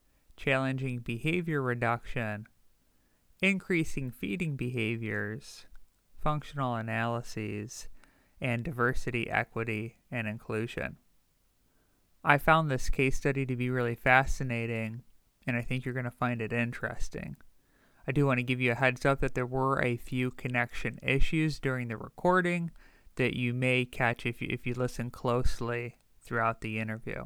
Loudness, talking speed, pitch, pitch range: -31 LUFS, 140 wpm, 125 Hz, 115-135 Hz